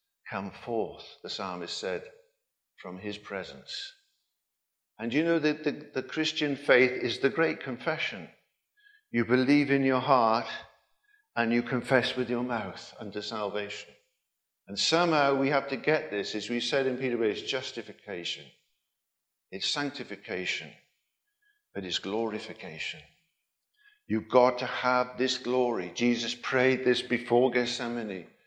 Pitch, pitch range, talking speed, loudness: 130 Hz, 120-160 Hz, 135 wpm, -29 LUFS